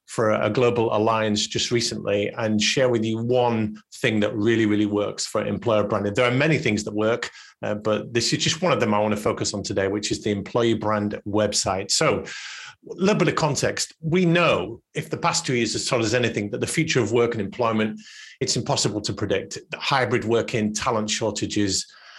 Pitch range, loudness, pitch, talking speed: 105-120 Hz, -23 LUFS, 110 Hz, 210 wpm